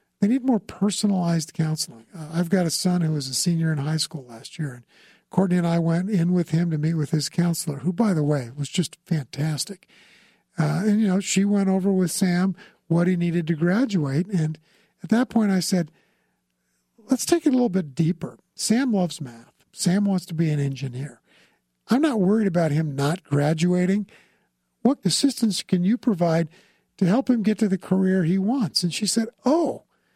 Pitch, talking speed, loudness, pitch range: 180 Hz, 200 wpm, -23 LUFS, 160-205 Hz